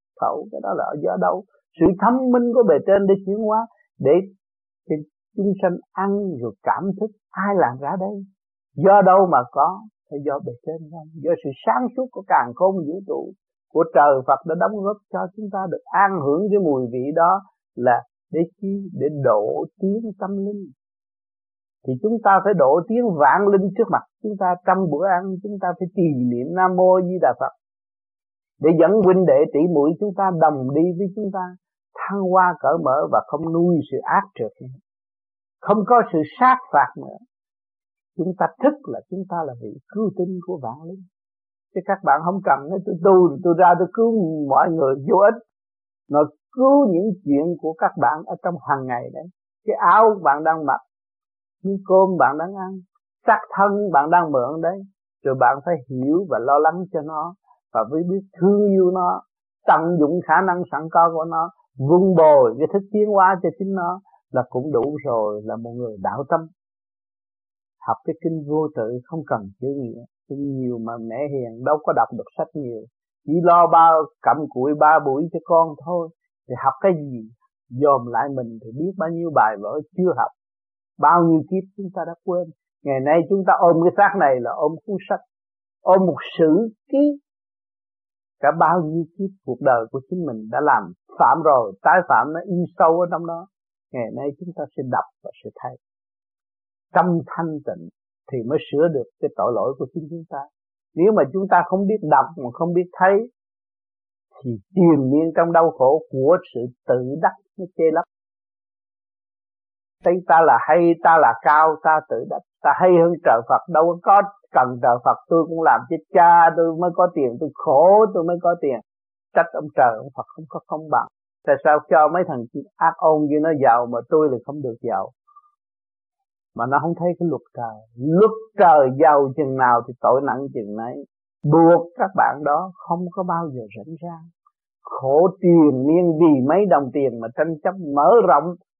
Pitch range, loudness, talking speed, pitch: 140-190 Hz, -19 LUFS, 195 wpm, 170 Hz